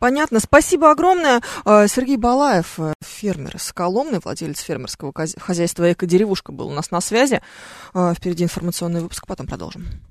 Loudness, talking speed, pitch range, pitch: -18 LUFS, 130 wpm, 170-245 Hz, 185 Hz